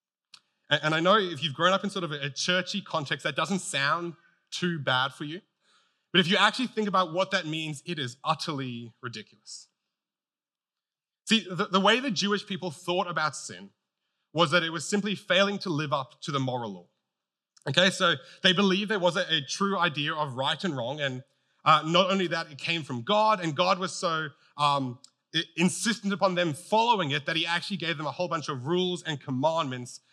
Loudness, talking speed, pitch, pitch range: -27 LUFS, 195 wpm, 170 Hz, 150-195 Hz